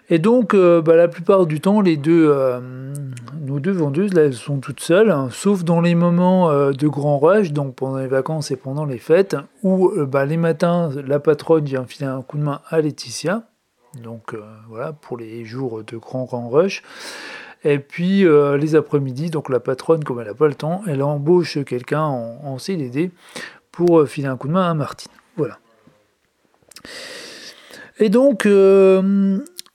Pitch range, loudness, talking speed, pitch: 135-175 Hz, -18 LUFS, 190 wpm, 150 Hz